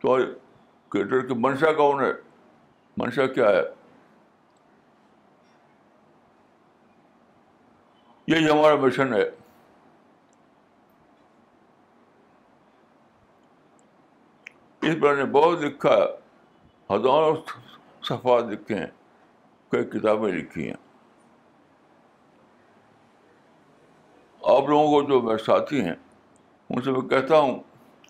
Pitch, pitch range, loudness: 145 Hz, 130-155 Hz, -23 LUFS